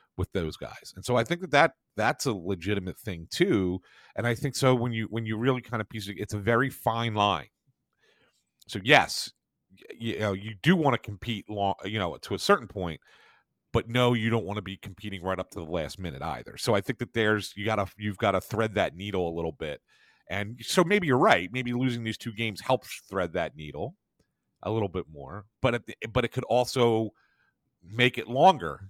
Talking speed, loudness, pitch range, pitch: 220 wpm, -28 LUFS, 100-120 Hz, 110 Hz